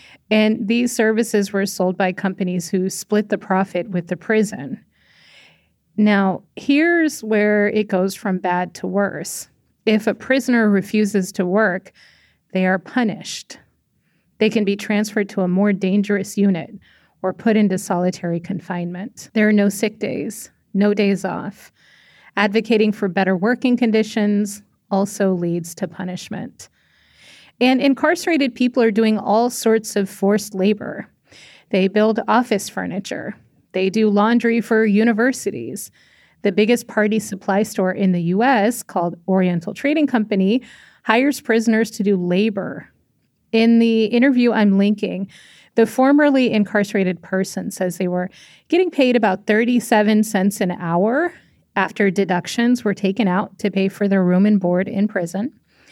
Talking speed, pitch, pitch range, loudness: 140 wpm, 205 Hz, 190-225 Hz, -19 LUFS